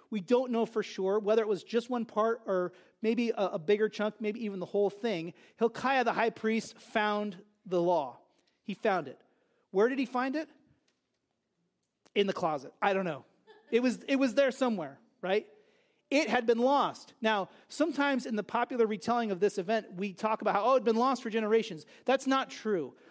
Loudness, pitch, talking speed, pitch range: -31 LUFS, 225 Hz, 200 wpm, 205-250 Hz